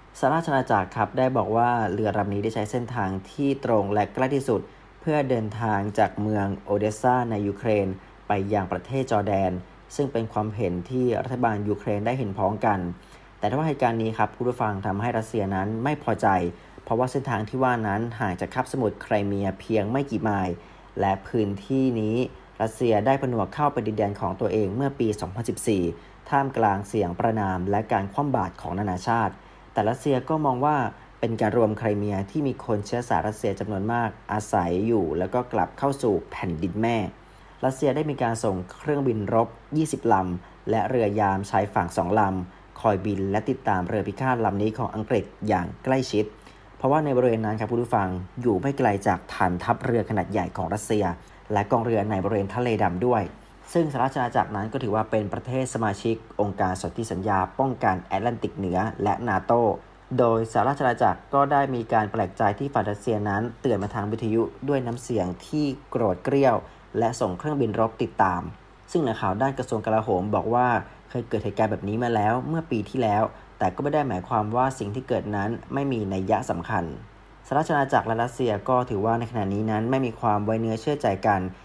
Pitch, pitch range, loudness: 110 Hz, 100-125 Hz, -25 LUFS